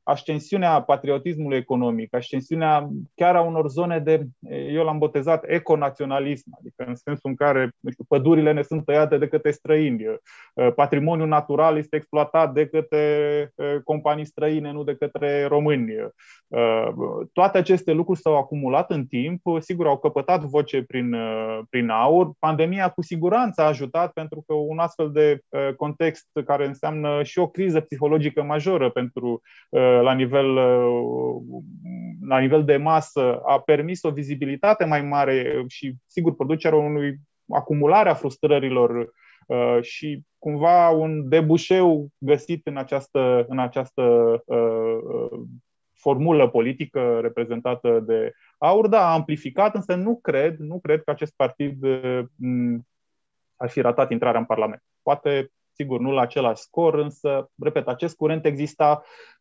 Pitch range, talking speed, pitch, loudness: 135-160 Hz, 135 wpm, 150 Hz, -22 LUFS